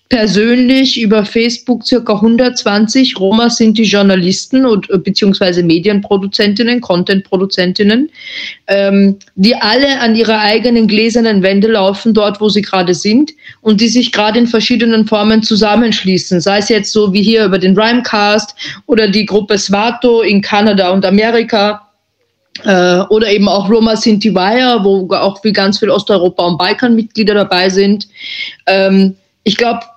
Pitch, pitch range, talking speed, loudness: 215 Hz, 195-230 Hz, 145 wpm, -10 LUFS